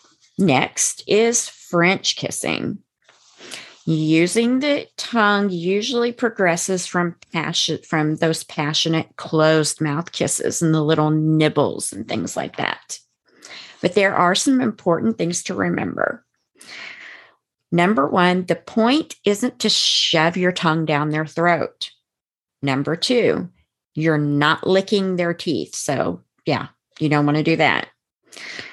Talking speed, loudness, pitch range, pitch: 125 wpm, -19 LUFS, 155-205 Hz, 170 Hz